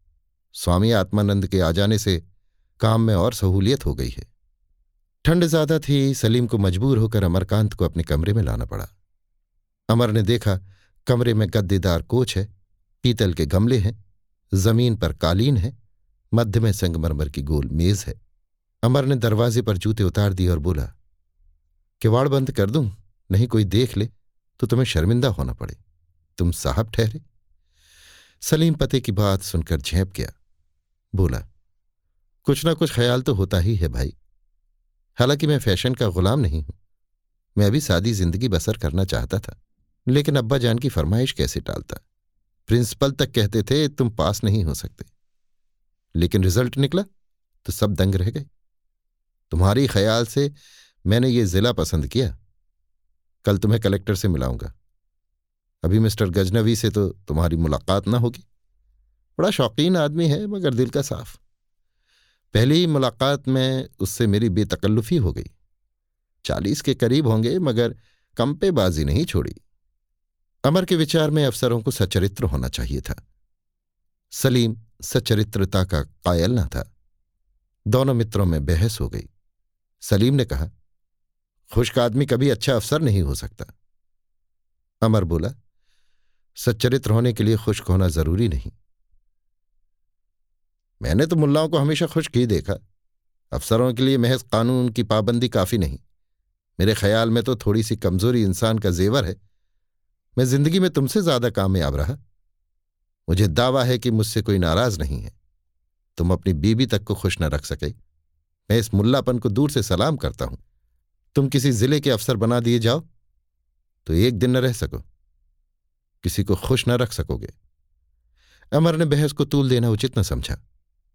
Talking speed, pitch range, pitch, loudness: 155 wpm, 85-120 Hz, 105 Hz, -21 LUFS